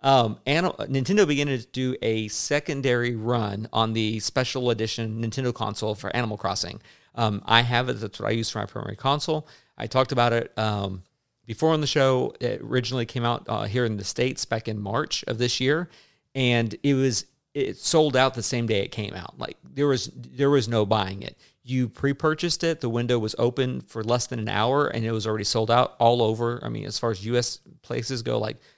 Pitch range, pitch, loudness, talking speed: 110-135 Hz, 120 Hz, -25 LUFS, 215 wpm